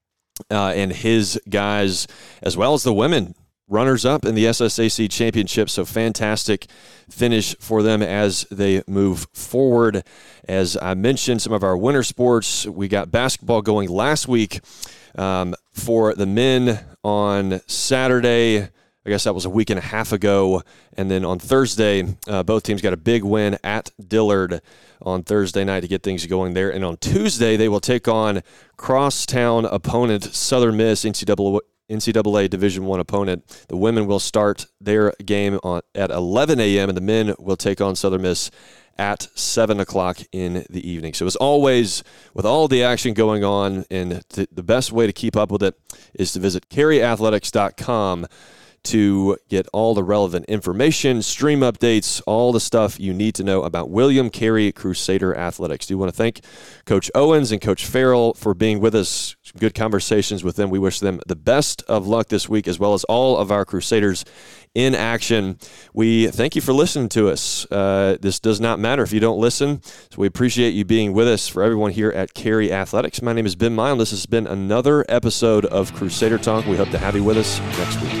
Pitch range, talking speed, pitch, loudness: 95-115 Hz, 190 wpm, 105 Hz, -19 LUFS